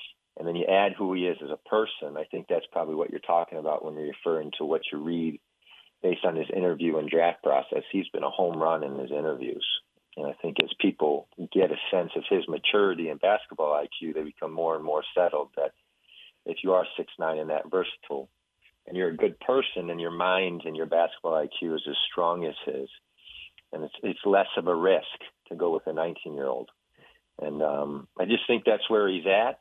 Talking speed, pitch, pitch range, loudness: 220 wpm, 85 Hz, 80-95 Hz, -28 LUFS